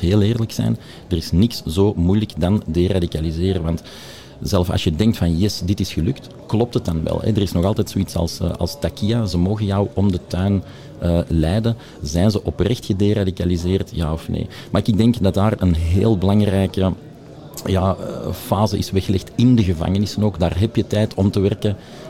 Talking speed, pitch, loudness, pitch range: 195 wpm, 100 Hz, -19 LUFS, 90-110 Hz